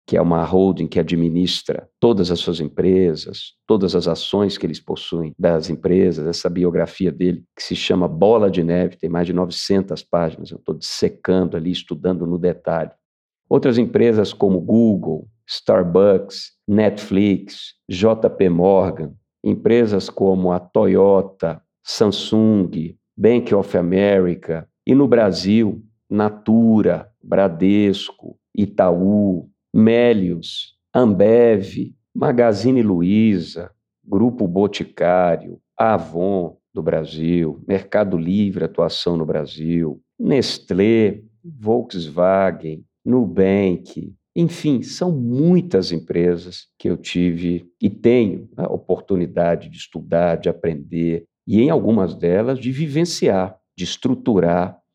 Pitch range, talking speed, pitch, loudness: 85-105 Hz, 110 wpm, 95 Hz, -18 LUFS